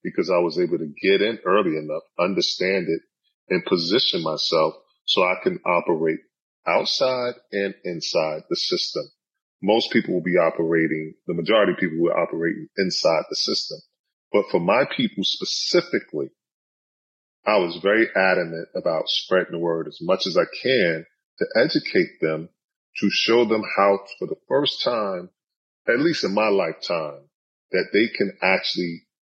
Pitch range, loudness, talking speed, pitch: 85-125 Hz, -22 LUFS, 155 wpm, 100 Hz